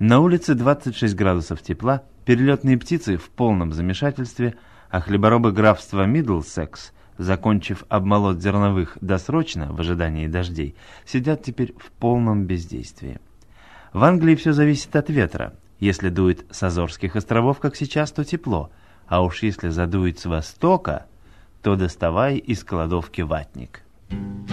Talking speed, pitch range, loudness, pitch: 125 wpm, 90-125 Hz, -21 LUFS, 100 Hz